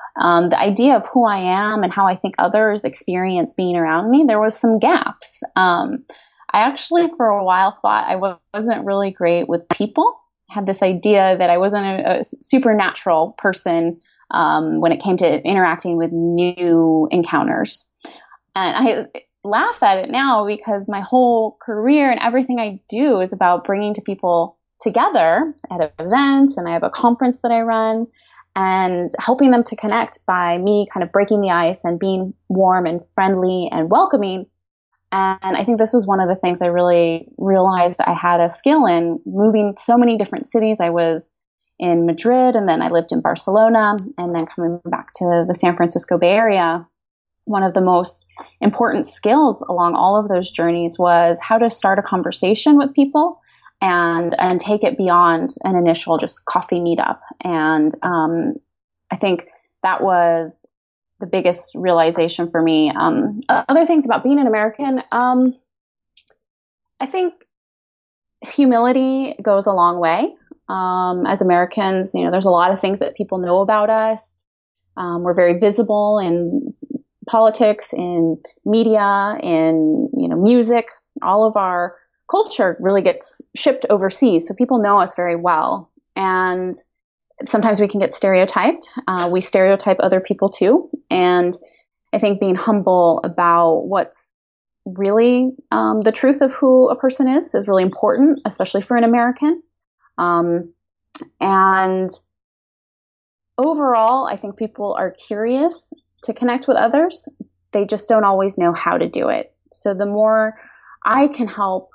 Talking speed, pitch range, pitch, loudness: 160 wpm, 175-235 Hz, 195 Hz, -17 LUFS